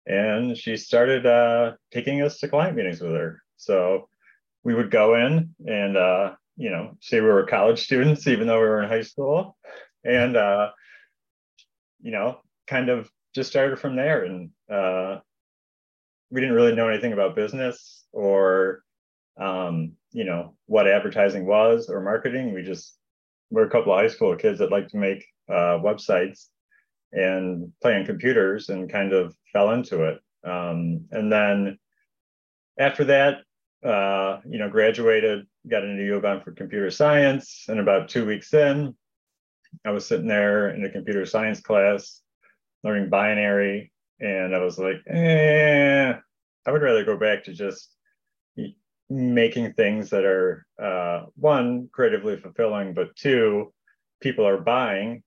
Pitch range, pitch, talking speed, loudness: 95-135 Hz, 110 Hz, 150 wpm, -22 LUFS